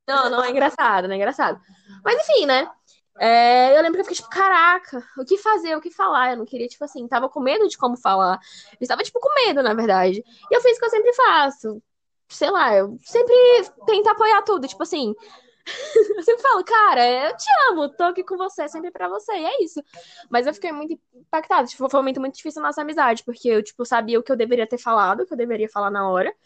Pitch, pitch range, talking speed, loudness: 275 Hz, 240-375 Hz, 240 wpm, -19 LUFS